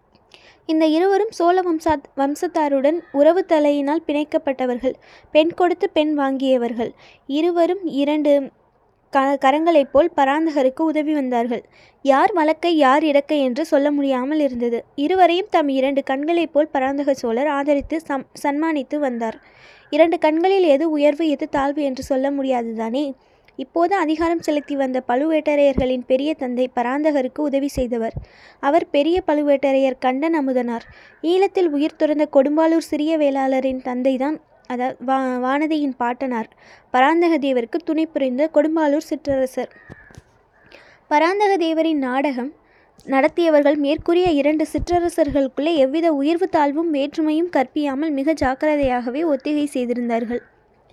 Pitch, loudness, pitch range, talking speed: 290 Hz, -19 LUFS, 270-320 Hz, 110 wpm